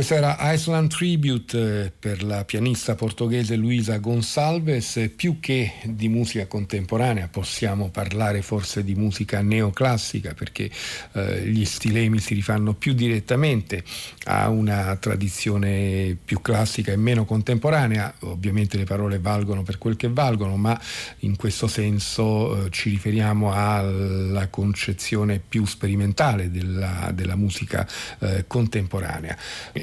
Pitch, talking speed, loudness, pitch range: 105 Hz, 120 wpm, -23 LUFS, 100-115 Hz